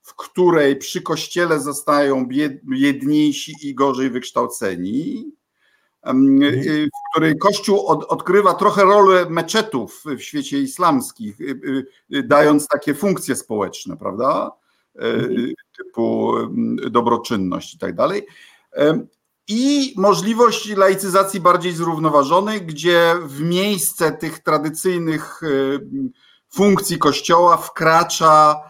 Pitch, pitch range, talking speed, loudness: 180 Hz, 150-225 Hz, 90 wpm, -17 LUFS